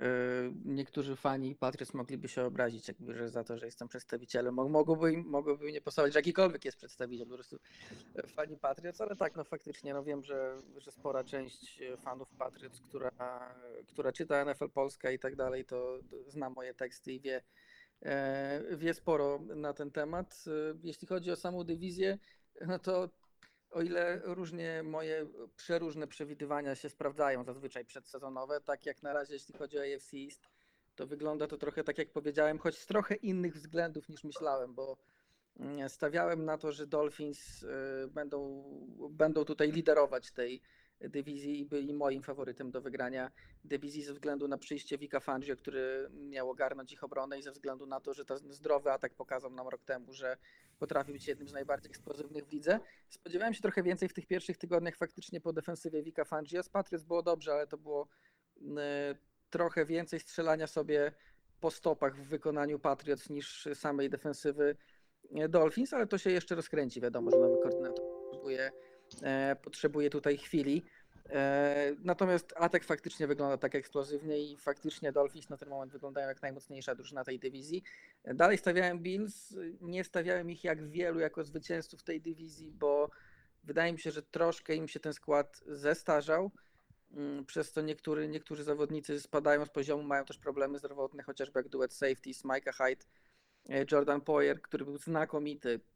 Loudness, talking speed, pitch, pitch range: -36 LUFS, 160 wpm, 145 Hz, 135-160 Hz